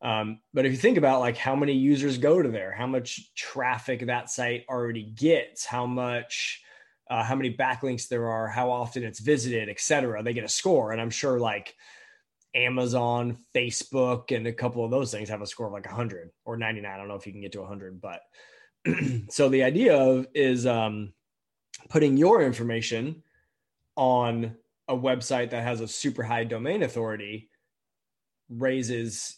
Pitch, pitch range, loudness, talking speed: 120 Hz, 115-130 Hz, -26 LUFS, 180 wpm